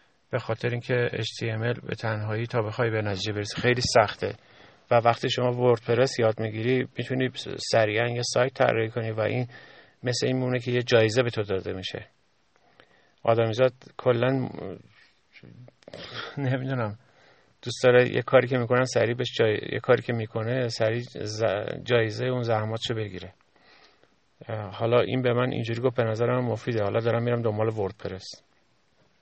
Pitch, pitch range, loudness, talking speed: 120 Hz, 110-125 Hz, -26 LUFS, 150 wpm